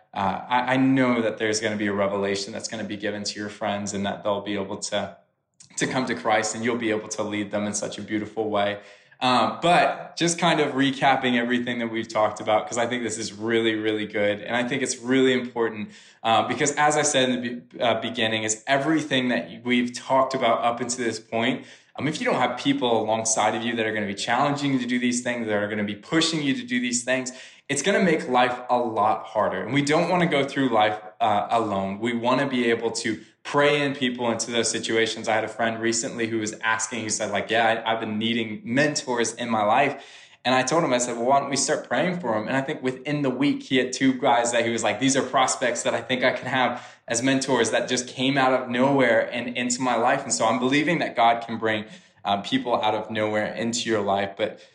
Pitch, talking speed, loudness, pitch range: 120 Hz, 250 wpm, -24 LUFS, 110-130 Hz